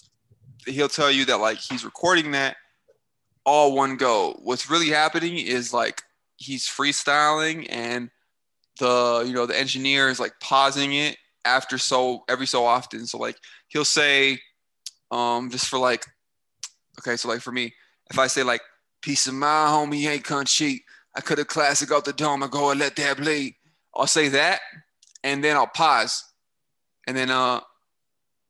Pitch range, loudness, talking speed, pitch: 125-150 Hz, -22 LUFS, 170 wpm, 135 Hz